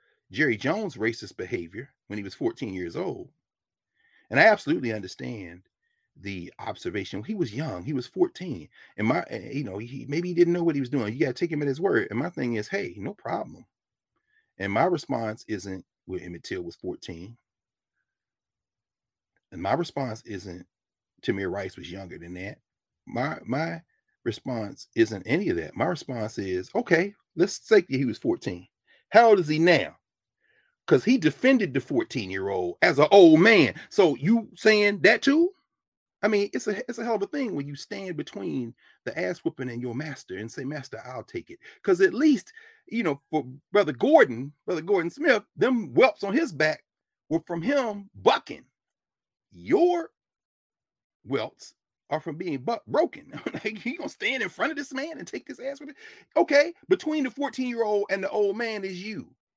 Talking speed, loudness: 185 wpm, -25 LUFS